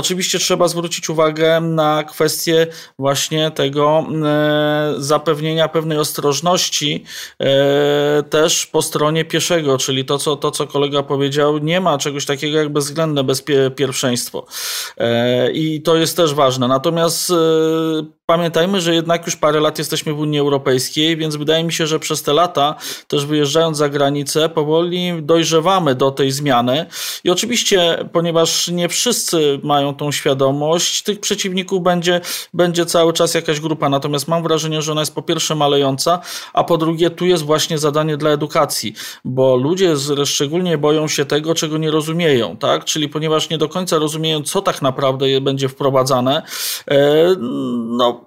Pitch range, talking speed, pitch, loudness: 145-165 Hz, 145 wpm, 155 Hz, -16 LUFS